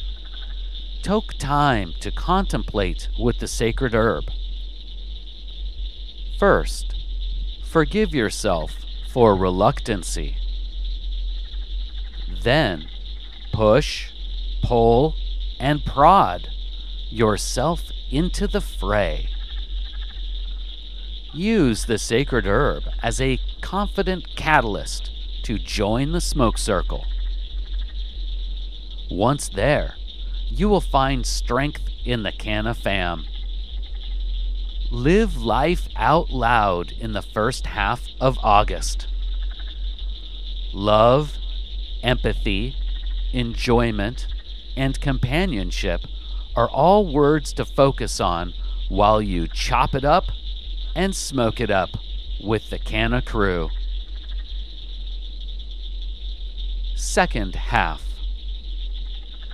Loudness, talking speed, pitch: -22 LUFS, 85 wpm, 75 Hz